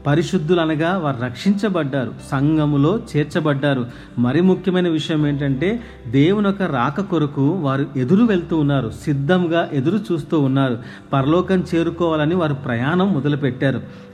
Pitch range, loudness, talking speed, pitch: 140-175 Hz, -19 LUFS, 115 wpm, 155 Hz